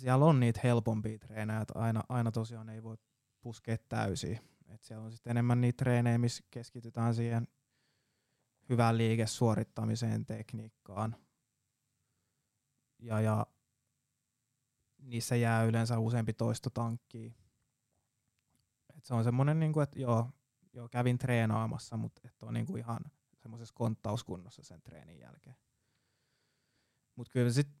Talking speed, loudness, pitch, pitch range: 115 wpm, -34 LUFS, 115 Hz, 115-125 Hz